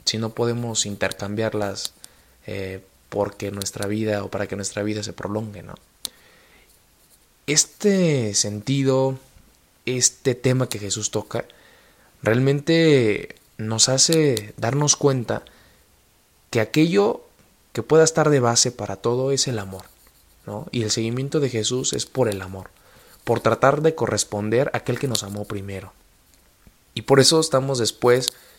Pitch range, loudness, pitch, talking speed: 105-130 Hz, -21 LUFS, 115 Hz, 135 wpm